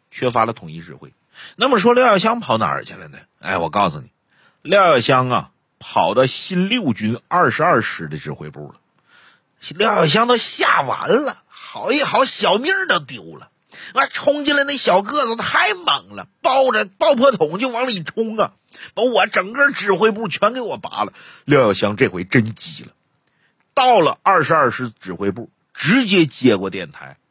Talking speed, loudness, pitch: 250 characters per minute, -17 LUFS, 195 Hz